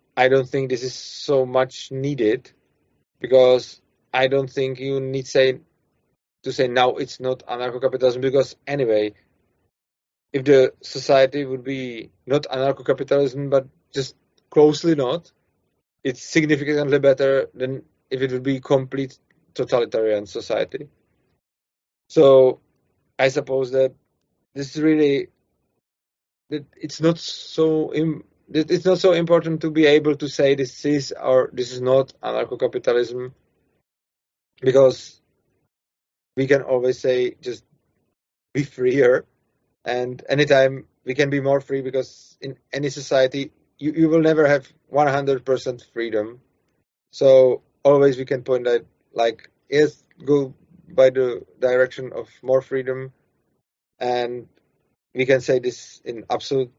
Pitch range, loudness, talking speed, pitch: 125-145 Hz, -20 LUFS, 130 wpm, 135 Hz